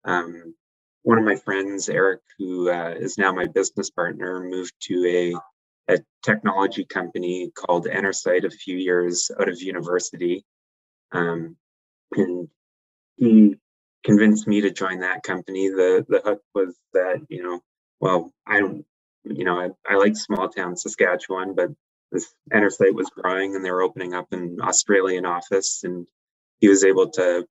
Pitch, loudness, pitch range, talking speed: 90 Hz, -22 LUFS, 85-95 Hz, 155 wpm